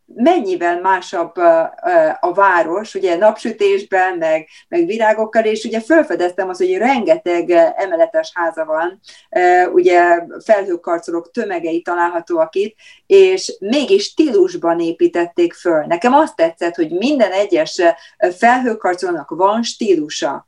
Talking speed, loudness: 110 wpm, -15 LUFS